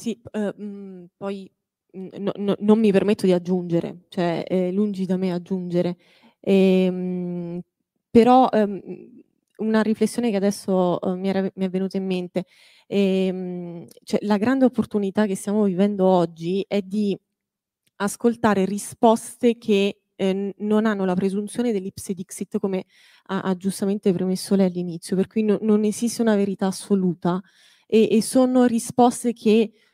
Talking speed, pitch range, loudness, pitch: 145 wpm, 185-215 Hz, -22 LUFS, 195 Hz